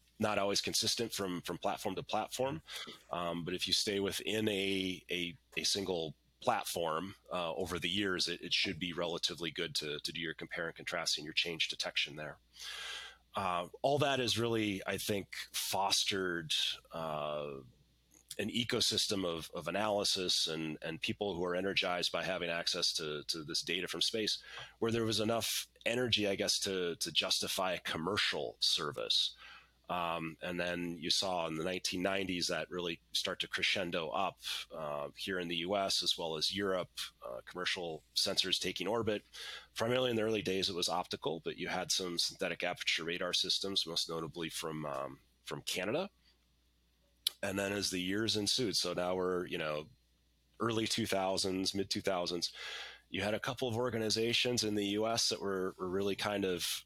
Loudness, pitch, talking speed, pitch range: -35 LUFS, 95 Hz, 170 wpm, 85-105 Hz